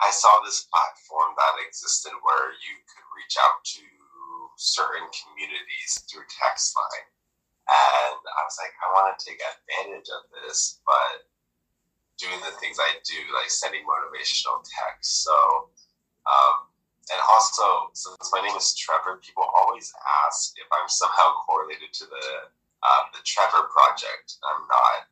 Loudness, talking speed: -23 LUFS, 150 wpm